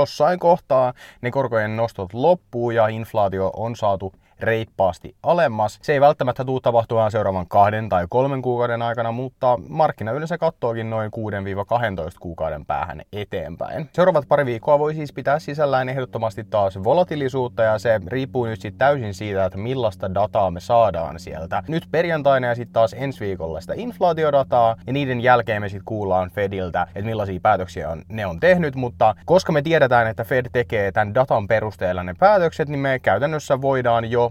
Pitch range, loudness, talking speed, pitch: 105-135 Hz, -21 LUFS, 165 wpm, 115 Hz